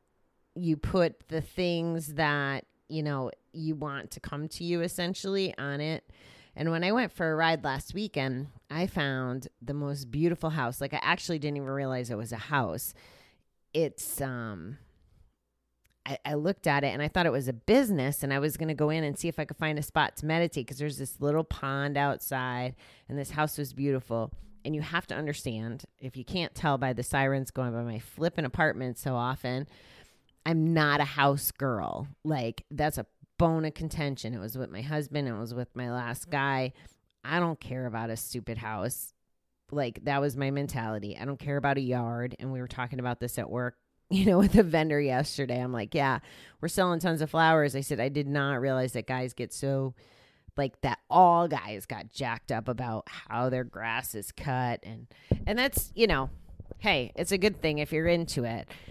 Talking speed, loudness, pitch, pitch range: 205 wpm, -30 LUFS, 140 Hz, 125-155 Hz